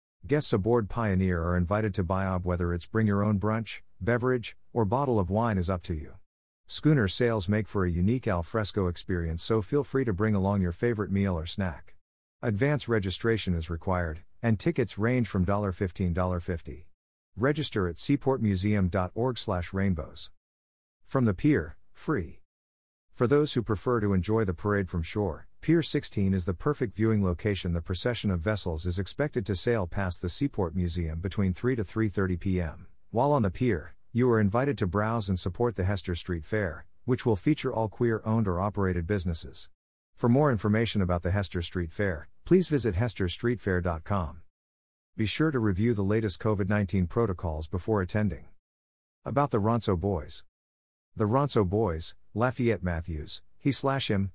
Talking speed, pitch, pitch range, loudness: 165 wpm, 100 Hz, 90-115 Hz, -28 LUFS